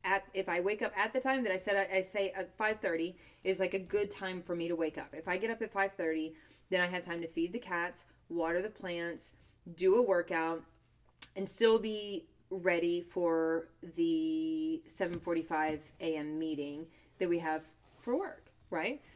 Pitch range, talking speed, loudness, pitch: 165-205 Hz, 190 wpm, -35 LUFS, 180 Hz